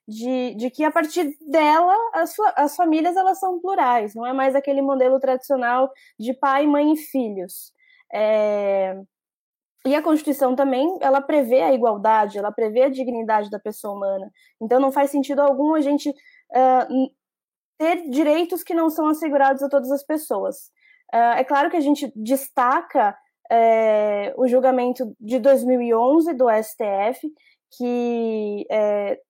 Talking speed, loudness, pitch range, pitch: 150 wpm, -20 LUFS, 235-305 Hz, 270 Hz